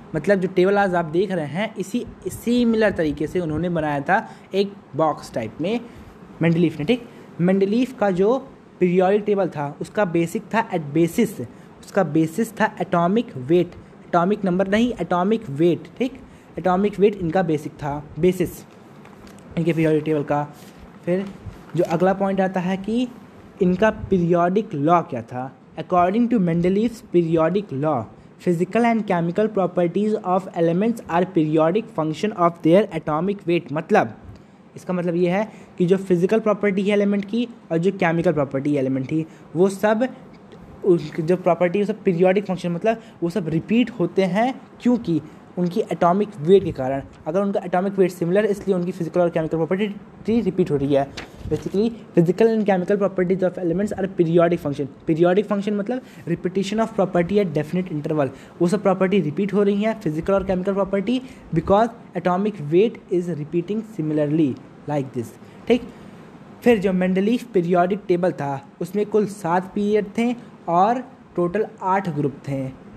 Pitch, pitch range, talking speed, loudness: 185 Hz, 170-210 Hz, 160 wpm, -21 LUFS